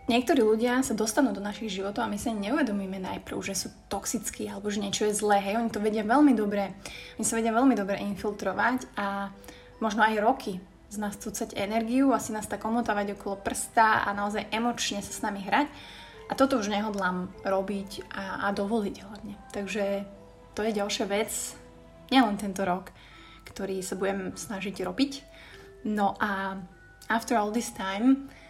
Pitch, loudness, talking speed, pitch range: 210 Hz, -28 LUFS, 170 wpm, 200-230 Hz